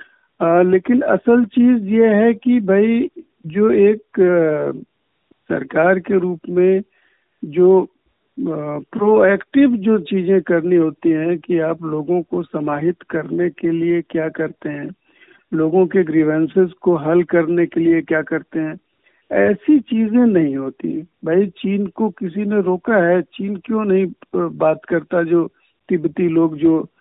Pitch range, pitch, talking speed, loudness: 165-205 Hz, 180 Hz, 140 wpm, -17 LUFS